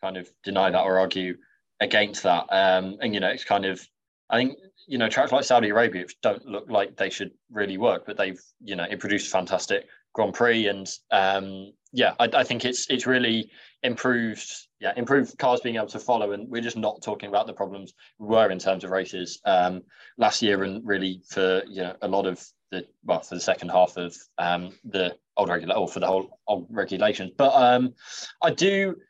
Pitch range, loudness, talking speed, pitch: 95-120 Hz, -25 LUFS, 210 wpm, 100 Hz